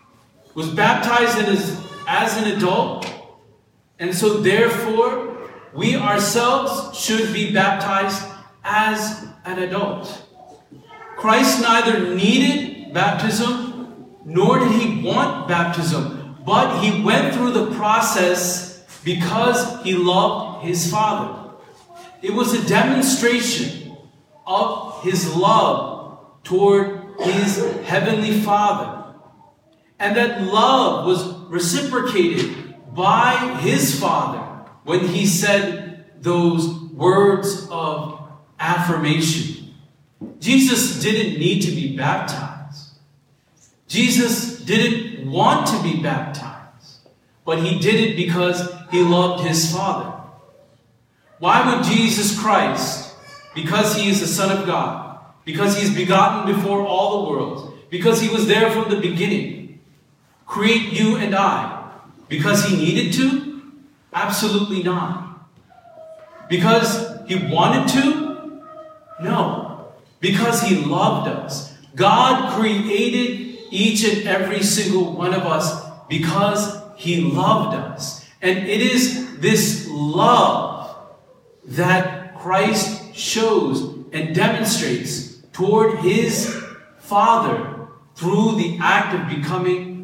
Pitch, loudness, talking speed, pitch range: 195 Hz, -18 LUFS, 105 wpm, 175-220 Hz